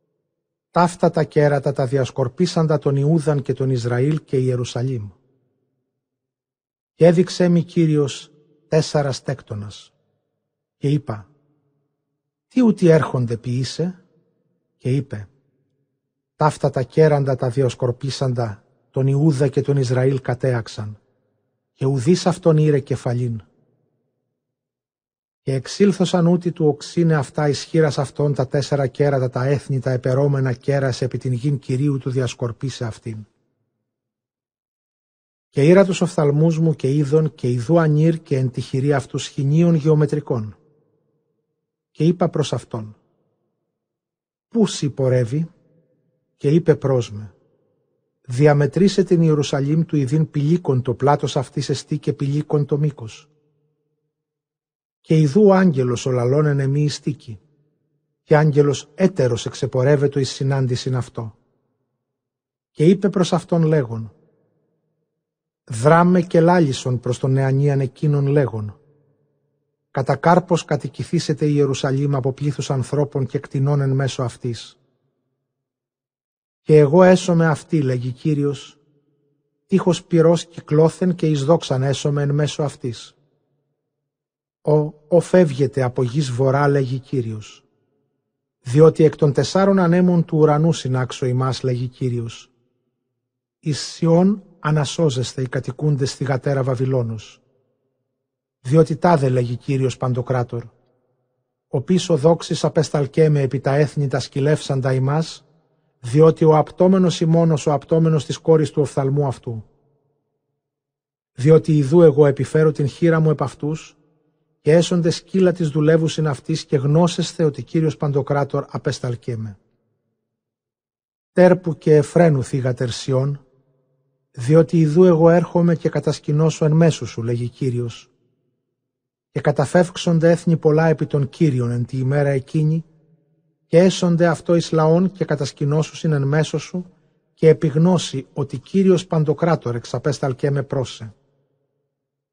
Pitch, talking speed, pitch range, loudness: 145 Hz, 120 wpm, 130-155 Hz, -18 LUFS